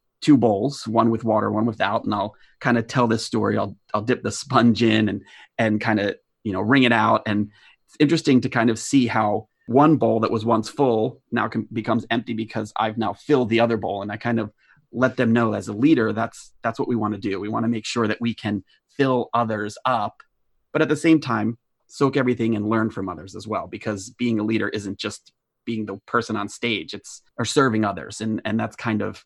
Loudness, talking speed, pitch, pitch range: -22 LUFS, 235 wpm, 115 Hz, 110-120 Hz